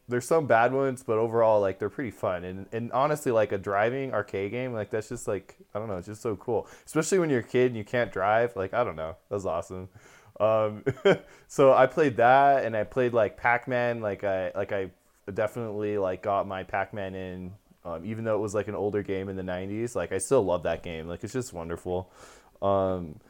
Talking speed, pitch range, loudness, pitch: 225 wpm, 95-120 Hz, -27 LUFS, 105 Hz